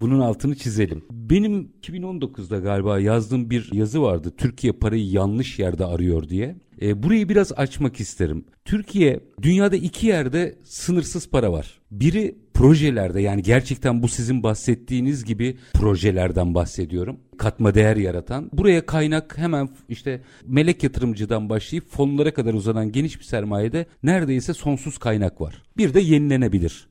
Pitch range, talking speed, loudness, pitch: 105-150 Hz, 135 wpm, -21 LUFS, 125 Hz